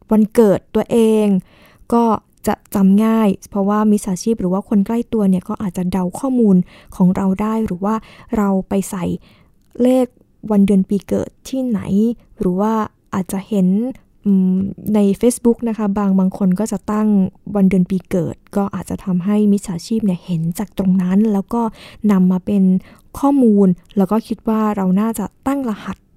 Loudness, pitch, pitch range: -17 LUFS, 205 Hz, 190-220 Hz